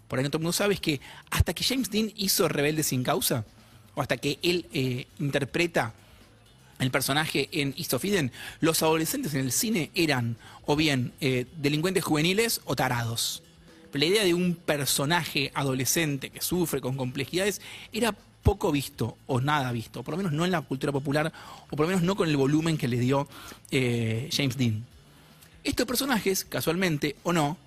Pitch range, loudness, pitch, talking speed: 130-170 Hz, -27 LUFS, 145 Hz, 180 wpm